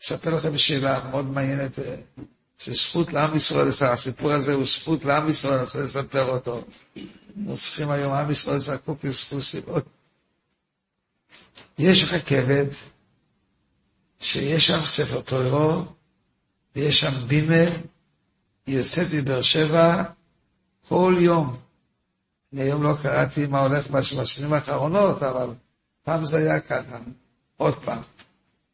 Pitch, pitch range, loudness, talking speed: 145 Hz, 135-160 Hz, -22 LUFS, 115 wpm